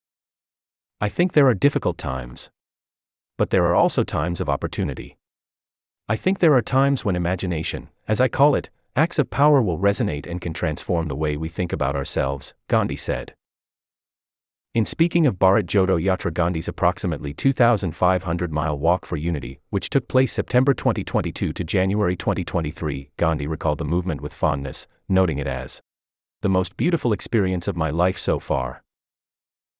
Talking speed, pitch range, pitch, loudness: 160 wpm, 75-110 Hz, 90 Hz, -22 LUFS